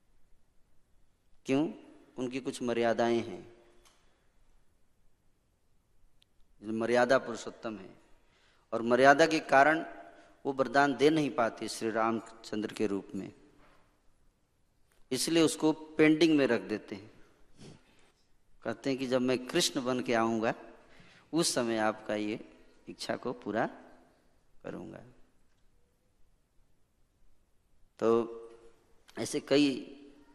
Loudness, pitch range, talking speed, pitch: -30 LUFS, 110-135 Hz, 95 wpm, 115 Hz